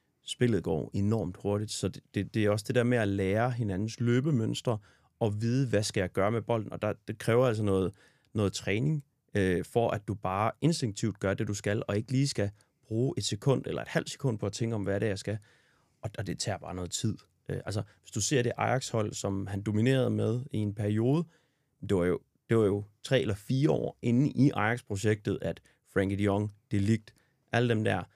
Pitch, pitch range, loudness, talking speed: 110 Hz, 100-125 Hz, -30 LUFS, 230 wpm